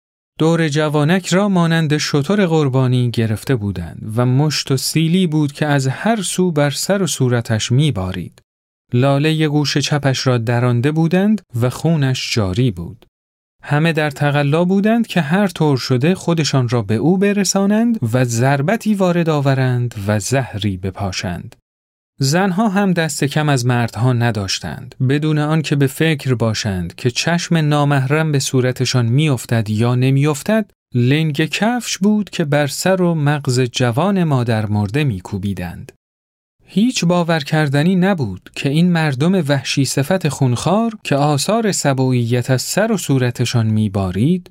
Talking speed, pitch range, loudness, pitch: 140 wpm, 120-165 Hz, -16 LUFS, 145 Hz